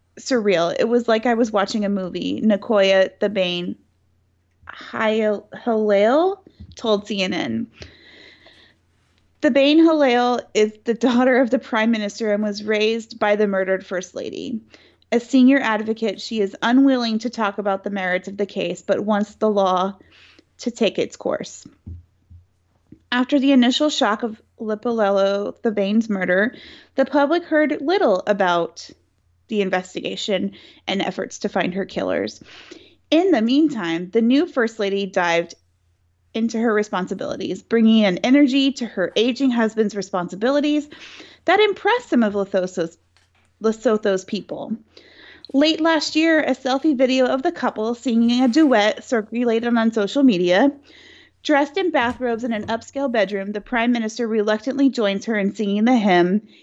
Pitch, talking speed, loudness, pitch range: 225 Hz, 145 wpm, -20 LUFS, 195-265 Hz